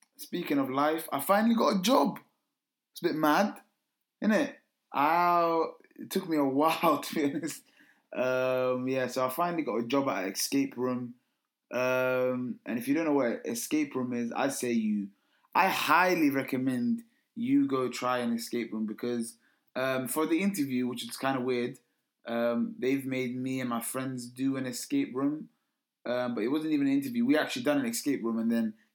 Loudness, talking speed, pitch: -30 LUFS, 195 wpm, 135 Hz